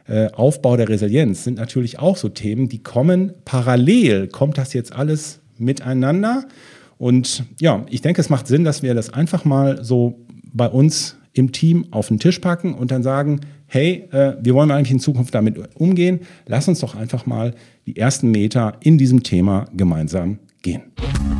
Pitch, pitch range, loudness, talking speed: 130 Hz, 120-150 Hz, -18 LUFS, 170 wpm